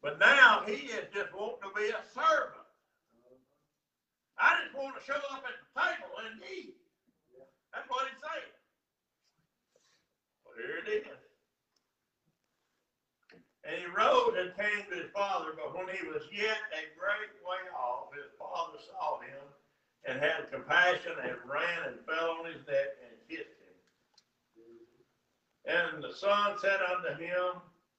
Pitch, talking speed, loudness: 210 Hz, 150 wpm, -32 LUFS